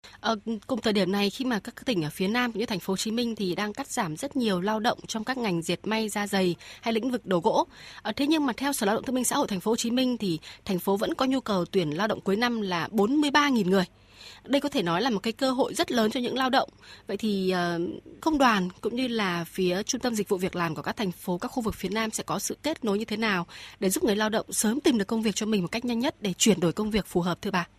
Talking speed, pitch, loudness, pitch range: 305 wpm, 215 Hz, -27 LUFS, 190-245 Hz